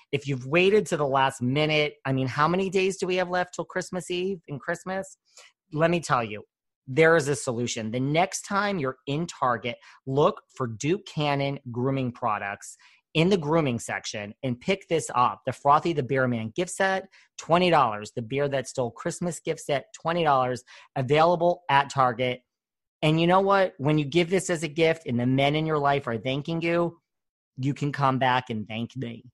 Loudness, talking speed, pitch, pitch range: -25 LUFS, 195 wpm, 145 Hz, 130-170 Hz